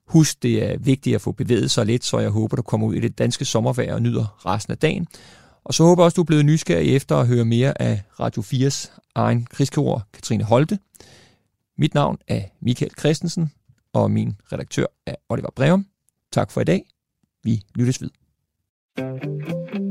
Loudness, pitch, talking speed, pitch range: -21 LUFS, 130 Hz, 185 wpm, 115-155 Hz